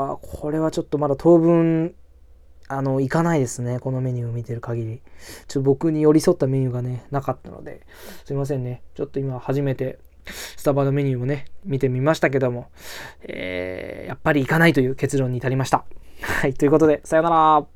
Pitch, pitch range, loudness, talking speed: 135 Hz, 125-155 Hz, -21 LUFS, 410 characters per minute